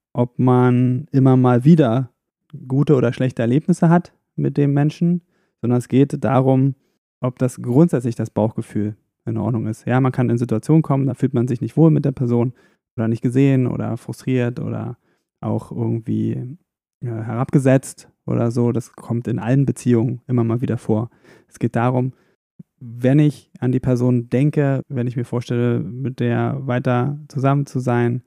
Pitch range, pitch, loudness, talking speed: 120-135 Hz, 125 Hz, -19 LUFS, 170 wpm